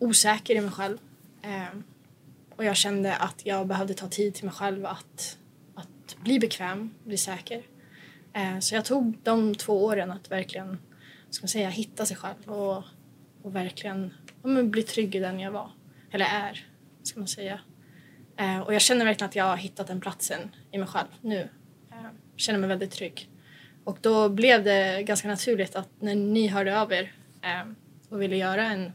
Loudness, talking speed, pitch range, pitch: -27 LUFS, 185 wpm, 185-210 Hz, 195 Hz